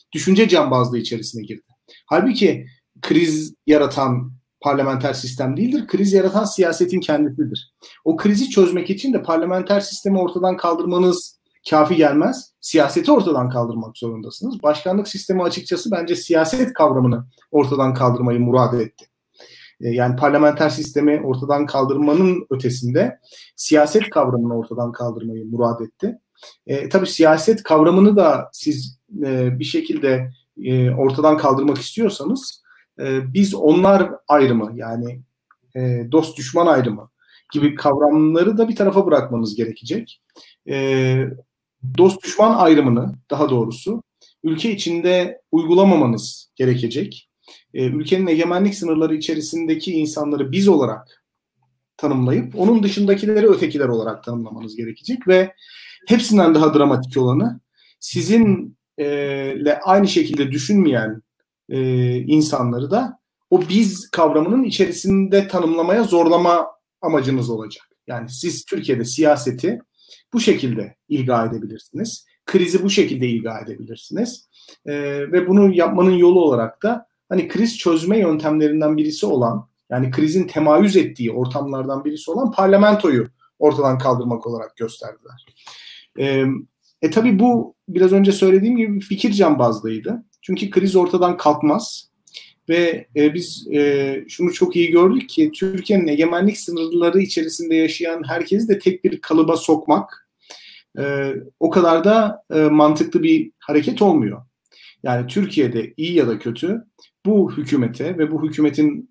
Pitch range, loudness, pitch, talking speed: 130-190 Hz, -17 LUFS, 155 Hz, 120 wpm